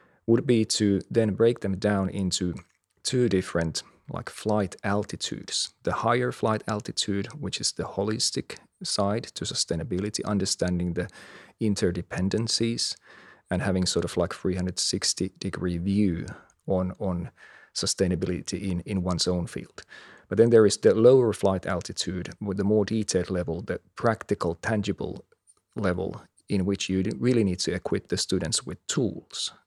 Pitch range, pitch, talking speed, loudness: 90-105 Hz, 95 Hz, 145 wpm, -26 LUFS